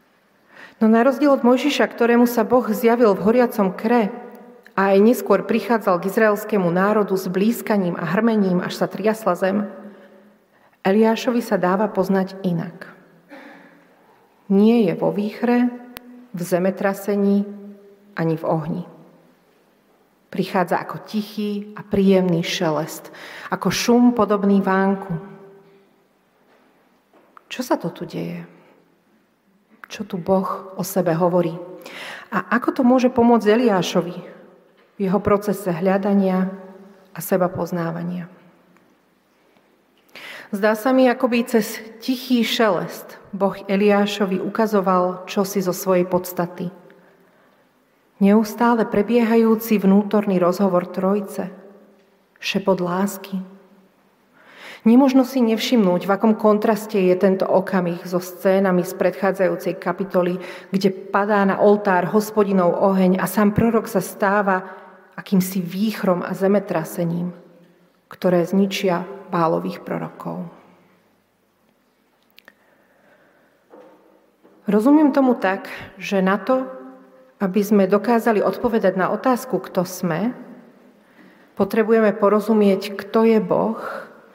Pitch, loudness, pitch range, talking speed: 195 Hz, -19 LUFS, 185-220 Hz, 105 wpm